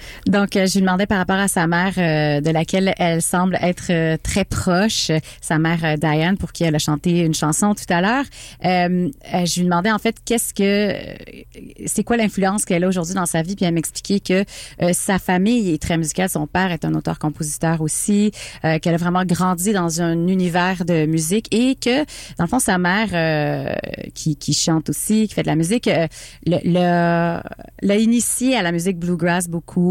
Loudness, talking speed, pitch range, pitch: -19 LUFS, 200 wpm, 165-195 Hz, 175 Hz